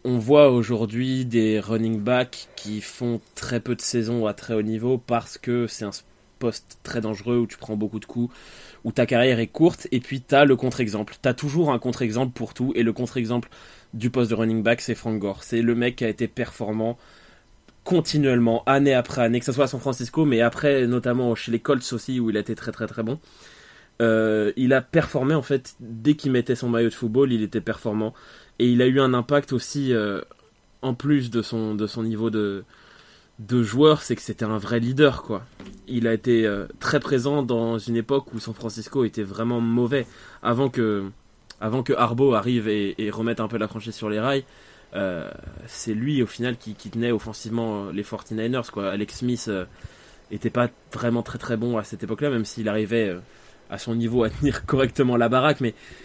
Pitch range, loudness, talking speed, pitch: 110-130 Hz, -23 LUFS, 215 wpm, 120 Hz